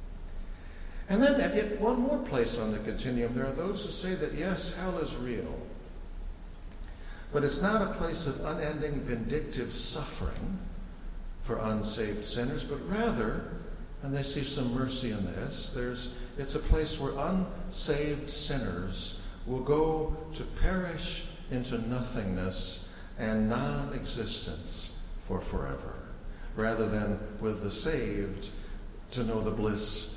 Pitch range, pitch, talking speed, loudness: 100-150 Hz, 120 Hz, 130 wpm, -33 LUFS